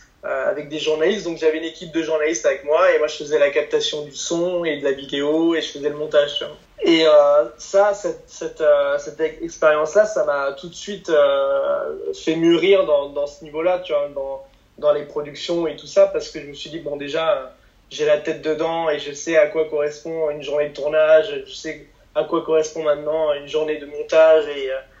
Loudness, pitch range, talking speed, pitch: -20 LUFS, 150-170 Hz, 230 wpm, 155 Hz